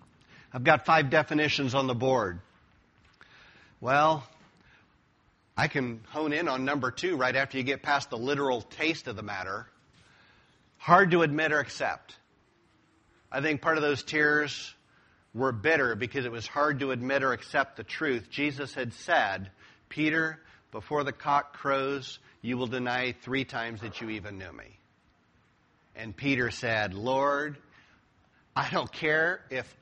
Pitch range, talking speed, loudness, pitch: 120-150 Hz, 150 wpm, -28 LUFS, 135 Hz